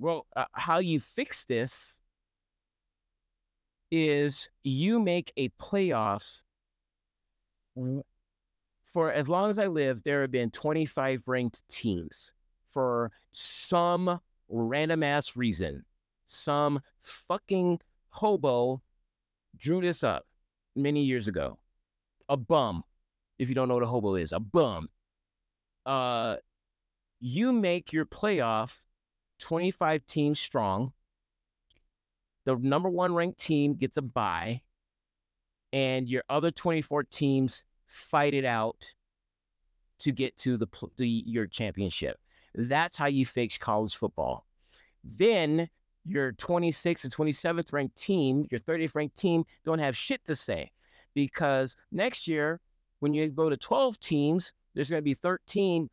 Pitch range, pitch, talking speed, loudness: 110-160 Hz, 135 Hz, 125 wpm, -30 LUFS